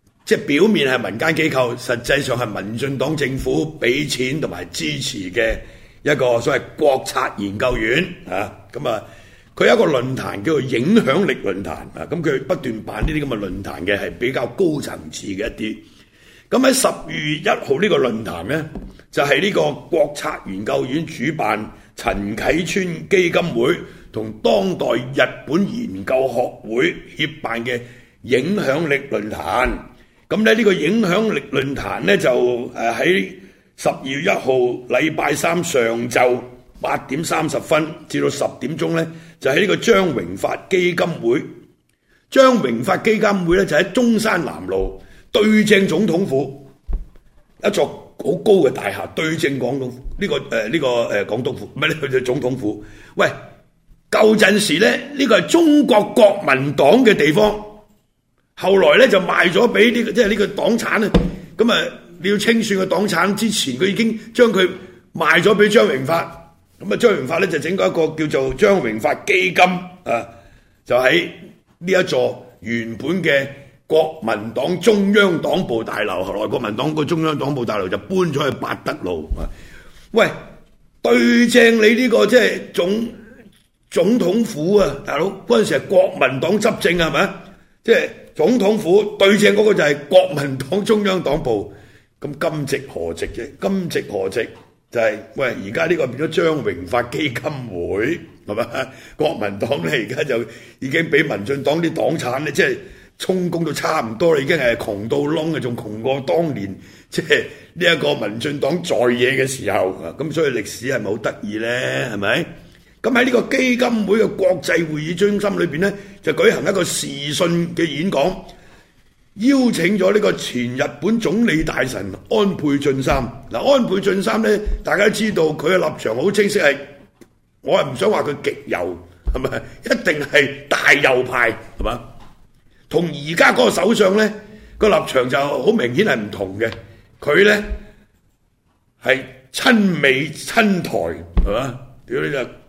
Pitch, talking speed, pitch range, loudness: 160 Hz, 240 characters per minute, 125-205 Hz, -18 LUFS